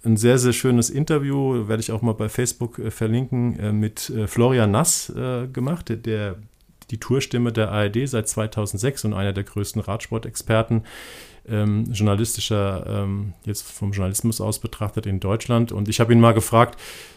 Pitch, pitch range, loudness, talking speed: 110 Hz, 105-120 Hz, -22 LUFS, 155 wpm